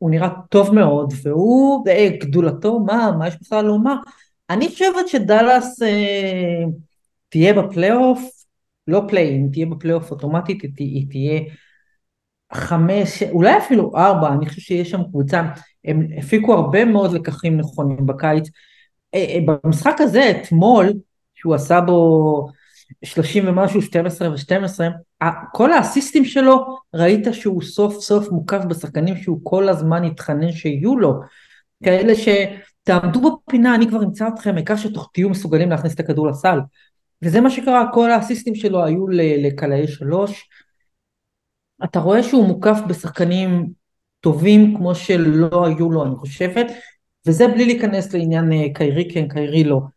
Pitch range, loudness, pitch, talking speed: 160-210 Hz, -17 LUFS, 180 Hz, 135 wpm